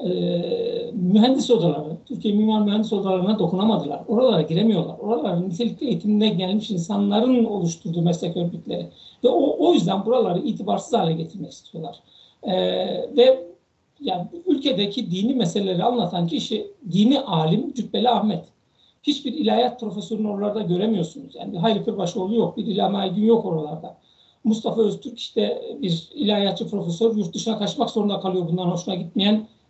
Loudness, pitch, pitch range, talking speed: -22 LUFS, 210 Hz, 180-230 Hz, 135 wpm